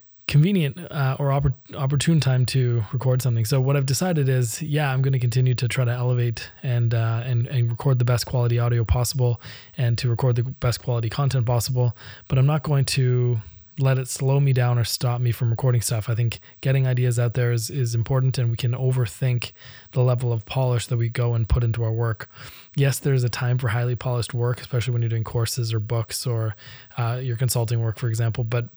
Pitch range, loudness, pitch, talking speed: 120-130 Hz, -23 LUFS, 125 Hz, 220 wpm